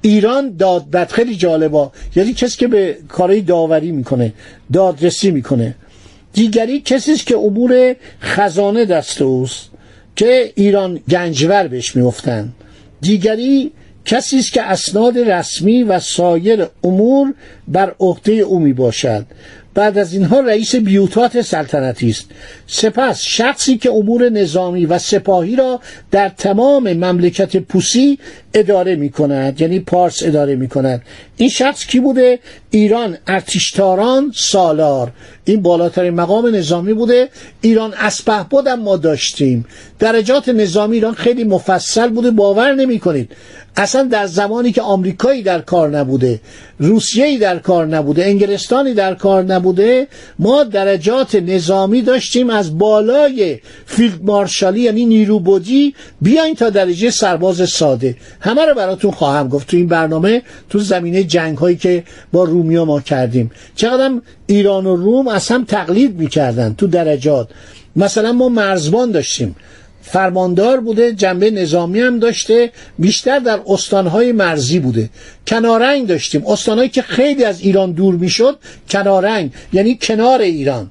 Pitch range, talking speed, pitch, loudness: 170-235 Hz, 130 wpm, 195 Hz, -13 LUFS